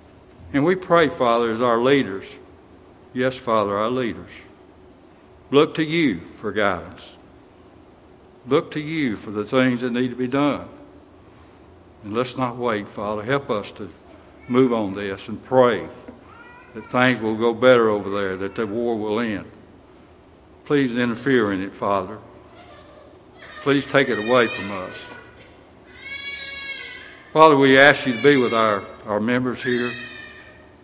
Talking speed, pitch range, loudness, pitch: 145 wpm, 105-135 Hz, -20 LUFS, 125 Hz